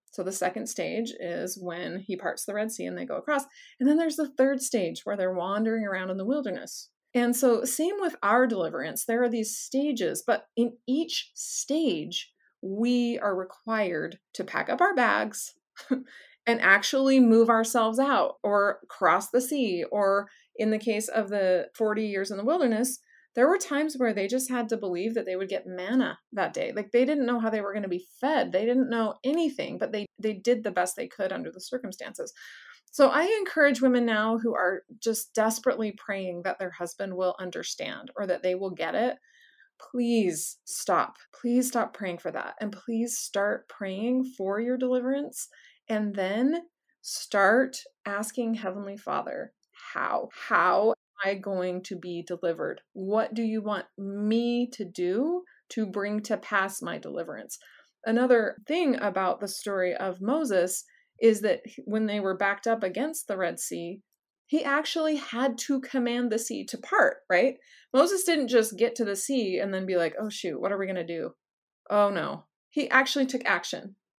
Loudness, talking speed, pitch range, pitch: -27 LUFS, 185 wpm, 195-260 Hz, 225 Hz